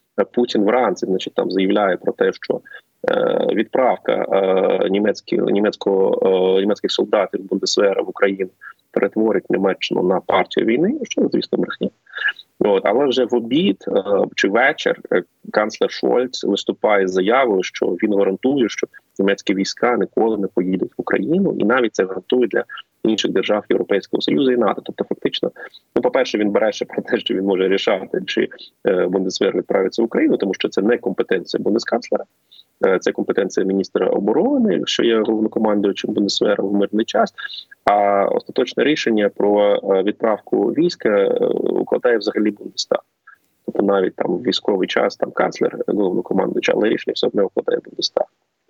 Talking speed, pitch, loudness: 150 wpm, 375 Hz, -19 LUFS